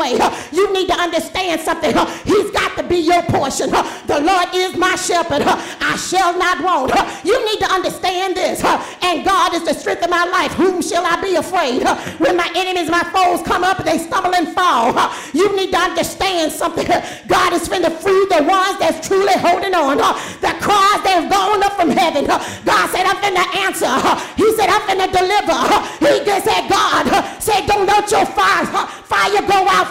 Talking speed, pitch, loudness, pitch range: 190 wpm, 370 Hz, -15 LUFS, 345-390 Hz